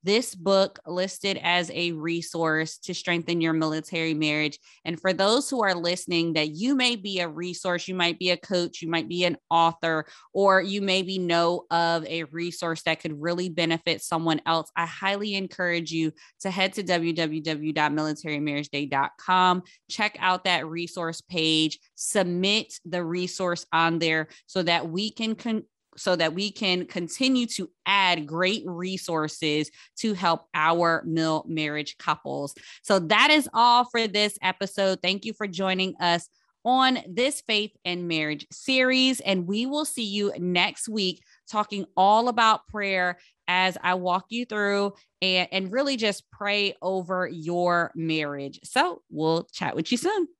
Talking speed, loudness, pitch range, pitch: 155 wpm, -25 LUFS, 165-200 Hz, 180 Hz